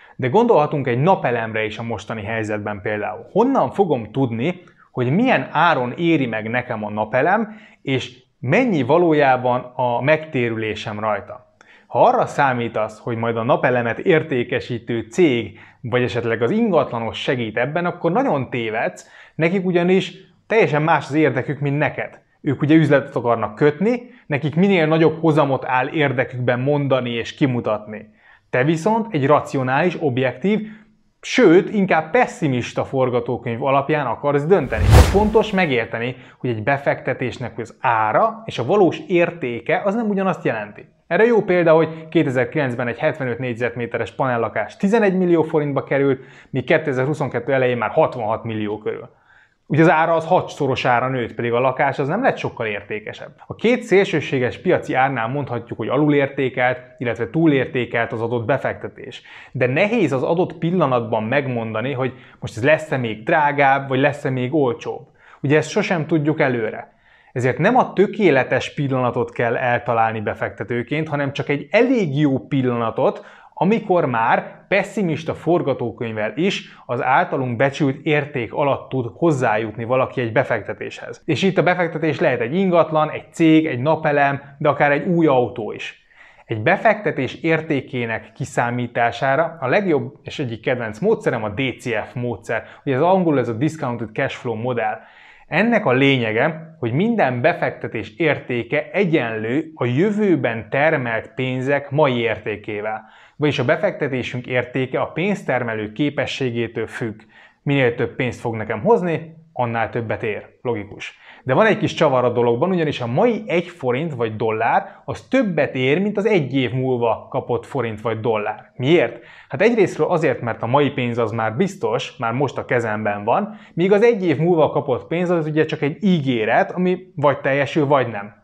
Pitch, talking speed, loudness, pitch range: 135 Hz, 150 wpm, -19 LUFS, 120-160 Hz